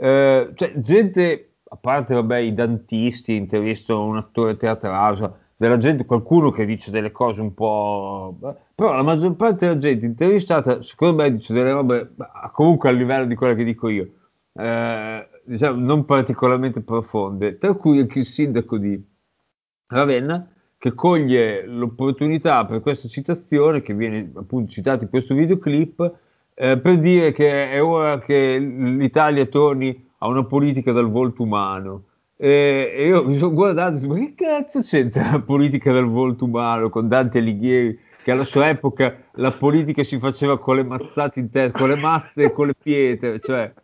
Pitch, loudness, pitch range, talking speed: 130 Hz, -19 LUFS, 115-145 Hz, 170 wpm